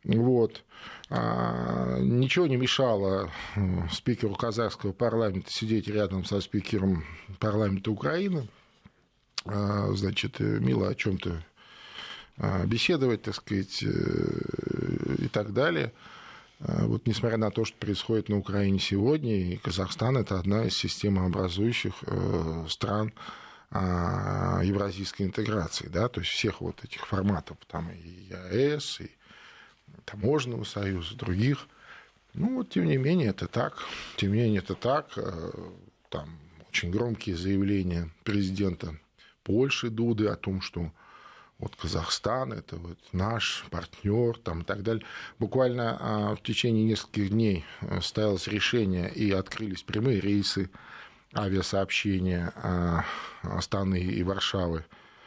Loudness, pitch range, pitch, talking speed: -29 LUFS, 95-115 Hz, 100 Hz, 110 wpm